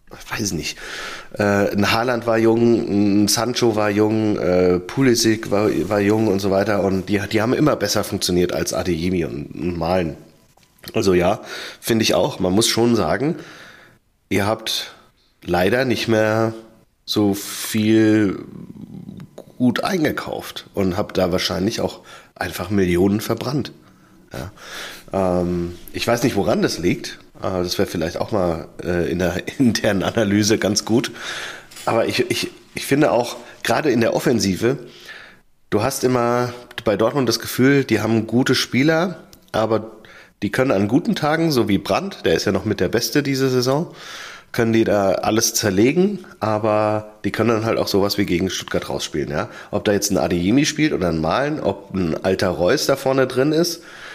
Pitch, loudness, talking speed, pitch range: 110 Hz, -19 LUFS, 165 wpm, 95-120 Hz